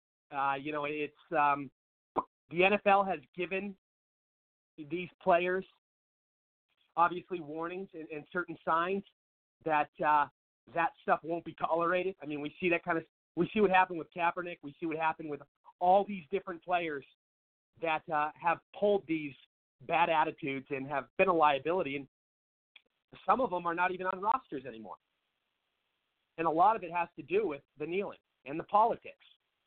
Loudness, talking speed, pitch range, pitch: -32 LUFS, 165 wpm, 145-180 Hz, 165 Hz